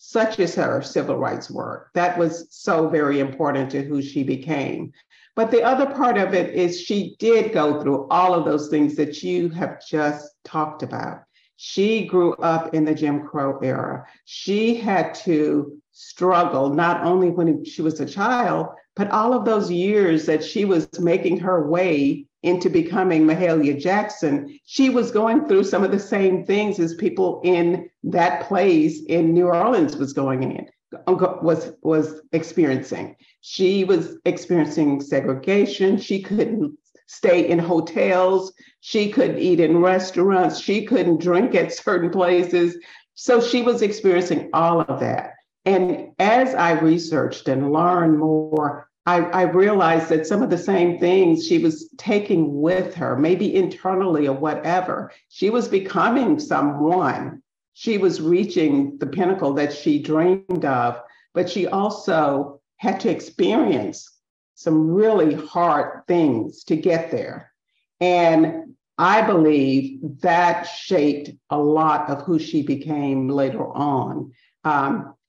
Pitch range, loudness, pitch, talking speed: 155-190 Hz, -20 LUFS, 175 Hz, 145 wpm